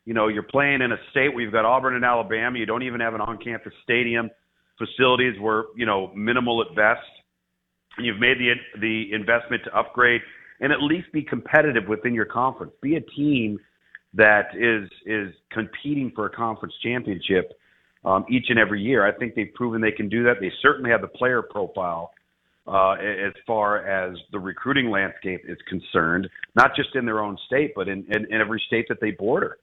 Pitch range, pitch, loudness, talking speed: 105-125 Hz, 115 Hz, -22 LUFS, 200 wpm